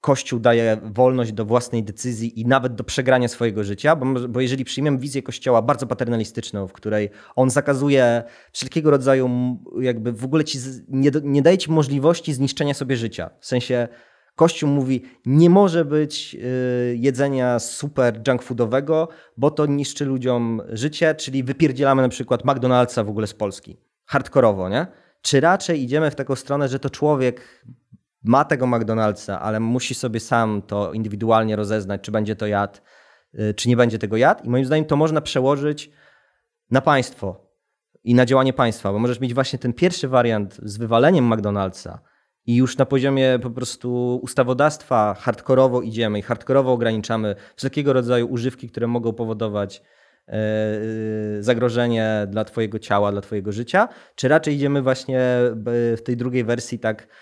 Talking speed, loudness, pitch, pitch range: 155 wpm, -20 LUFS, 125 Hz, 115-135 Hz